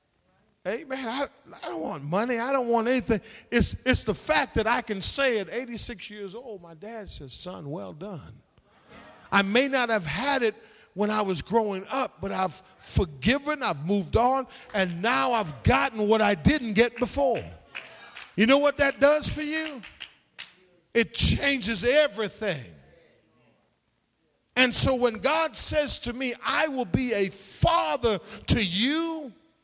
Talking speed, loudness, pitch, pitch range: 160 wpm, -25 LUFS, 230 Hz, 200-265 Hz